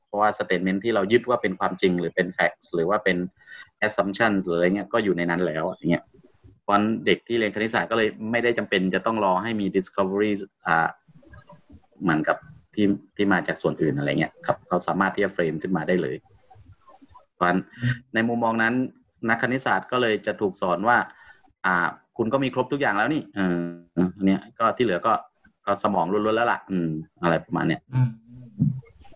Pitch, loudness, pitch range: 105 Hz, -24 LUFS, 95-115 Hz